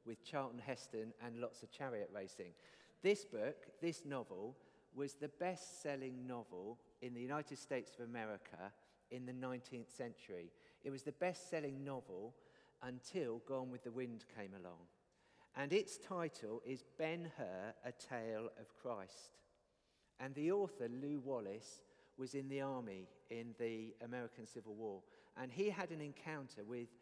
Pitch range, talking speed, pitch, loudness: 120-150 Hz, 155 wpm, 130 Hz, -47 LUFS